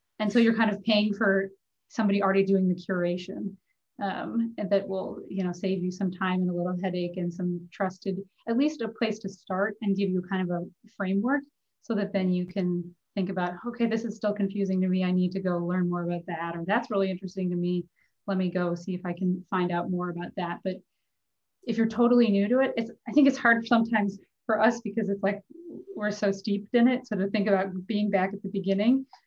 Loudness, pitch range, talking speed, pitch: -28 LUFS, 185-220 Hz, 235 wpm, 195 Hz